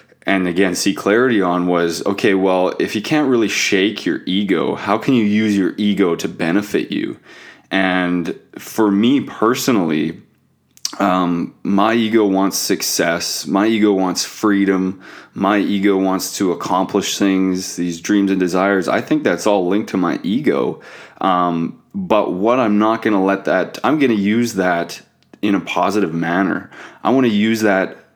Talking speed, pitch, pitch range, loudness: 165 wpm, 95 Hz, 90-105 Hz, -17 LUFS